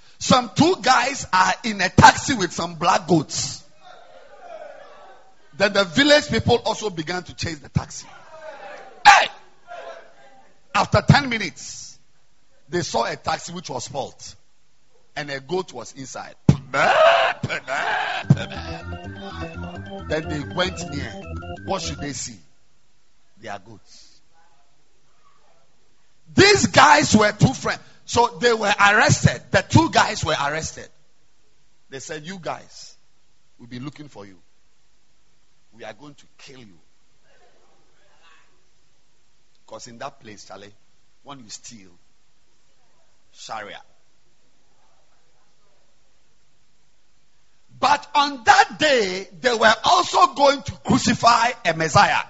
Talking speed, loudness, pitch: 110 wpm, -19 LUFS, 175 Hz